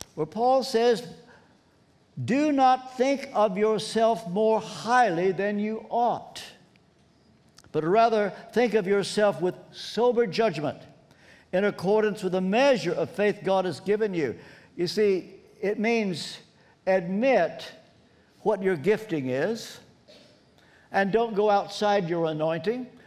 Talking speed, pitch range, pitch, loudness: 120 wpm, 185-225 Hz, 210 Hz, -25 LUFS